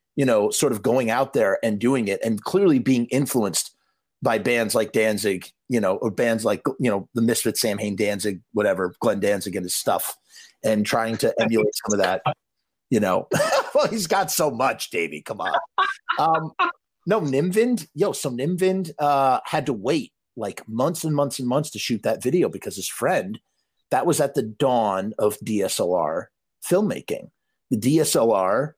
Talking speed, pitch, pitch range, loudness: 175 wpm, 135 Hz, 110-180 Hz, -22 LUFS